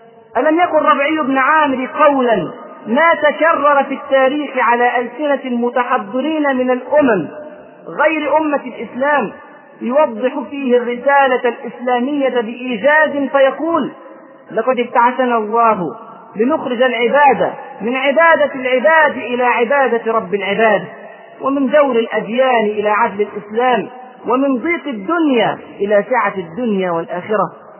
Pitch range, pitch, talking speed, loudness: 230-290 Hz, 255 Hz, 105 wpm, -15 LUFS